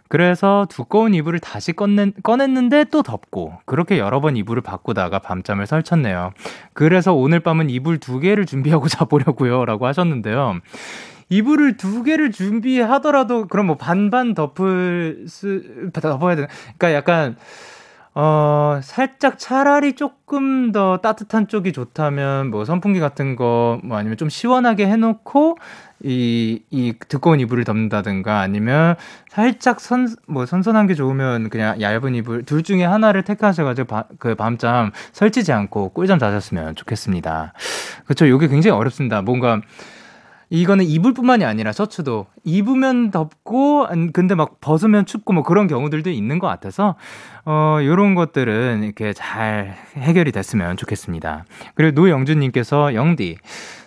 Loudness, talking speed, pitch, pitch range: -18 LUFS, 320 characters per minute, 160 Hz, 120-205 Hz